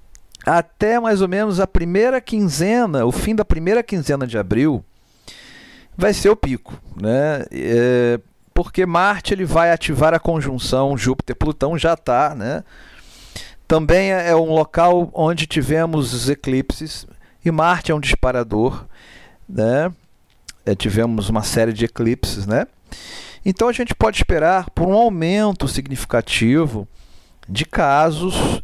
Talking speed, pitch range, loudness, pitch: 135 wpm, 125-185 Hz, -18 LUFS, 160 Hz